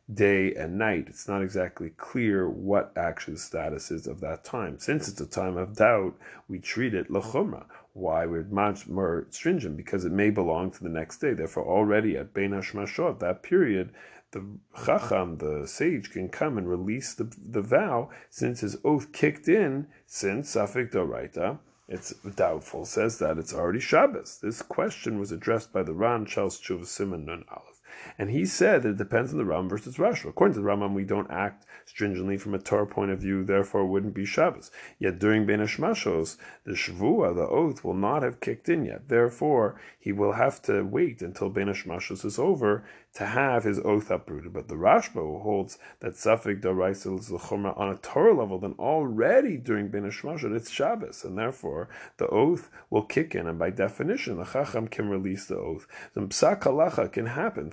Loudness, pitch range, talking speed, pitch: -28 LUFS, 95-105 Hz, 185 wpm, 100 Hz